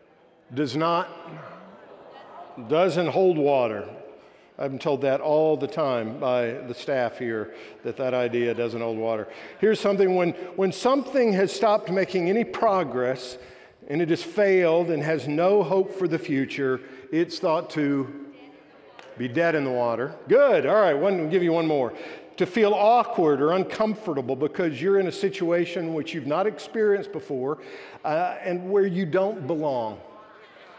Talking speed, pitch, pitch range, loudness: 155 wpm, 165 Hz, 135-190 Hz, -24 LUFS